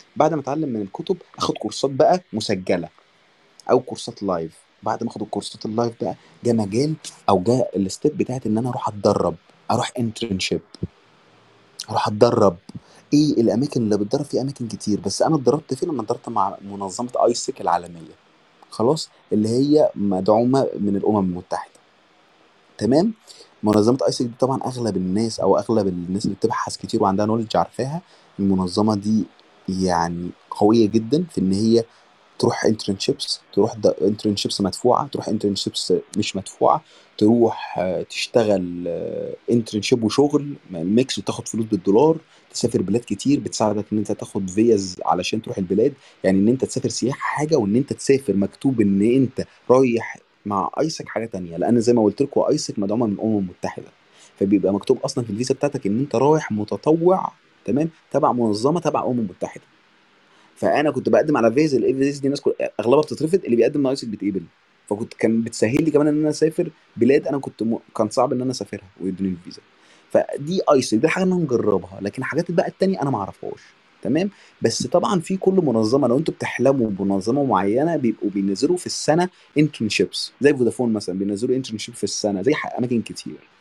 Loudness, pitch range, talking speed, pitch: -21 LUFS, 100-135 Hz, 160 wpm, 110 Hz